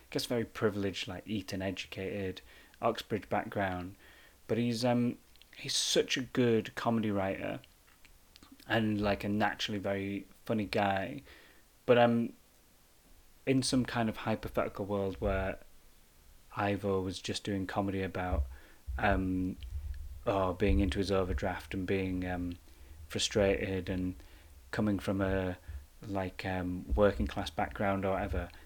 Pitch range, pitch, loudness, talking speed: 90-105 Hz, 95 Hz, -33 LUFS, 130 wpm